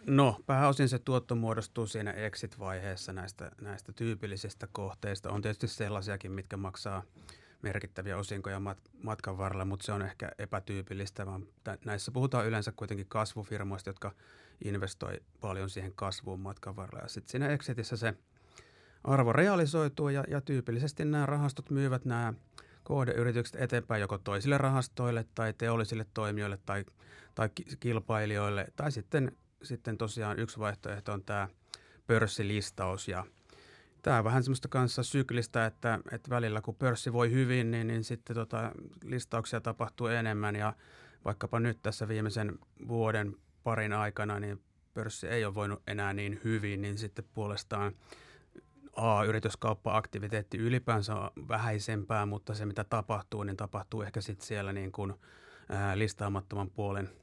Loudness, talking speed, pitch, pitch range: -35 LUFS, 135 wpm, 110 Hz, 100-120 Hz